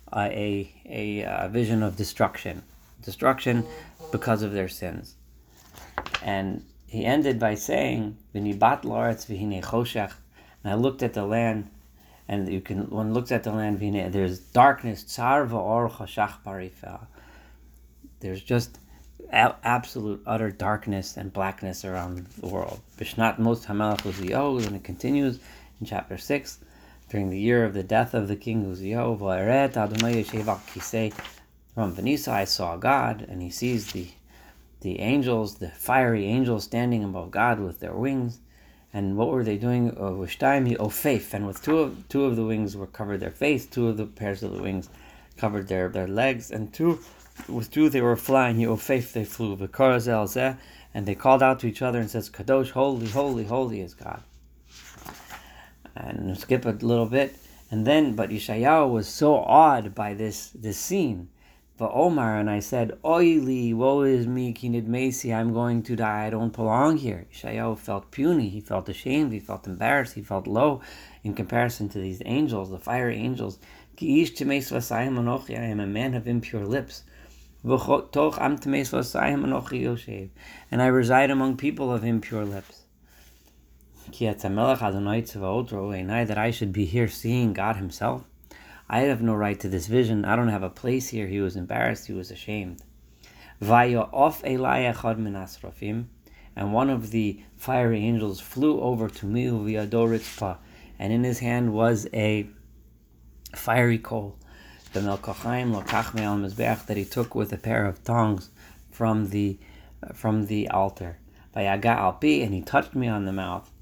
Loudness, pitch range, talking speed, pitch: -26 LUFS, 95-120 Hz, 150 wpm, 110 Hz